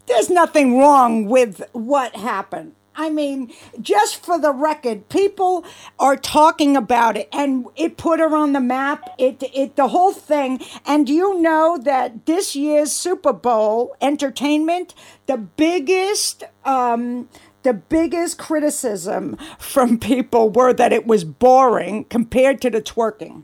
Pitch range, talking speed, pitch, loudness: 250-320 Hz, 140 wpm, 280 Hz, -17 LUFS